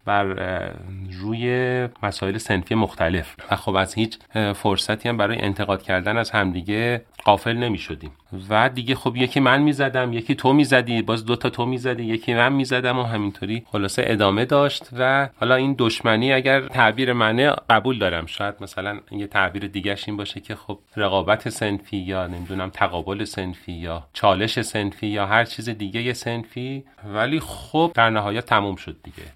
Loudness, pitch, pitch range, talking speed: -21 LUFS, 110 Hz, 100-125 Hz, 170 wpm